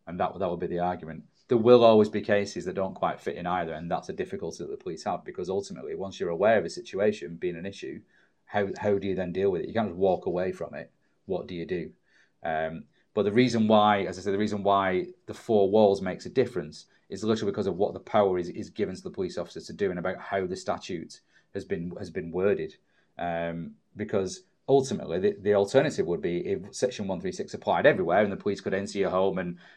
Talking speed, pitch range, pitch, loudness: 240 wpm, 95-125 Hz, 105 Hz, -28 LUFS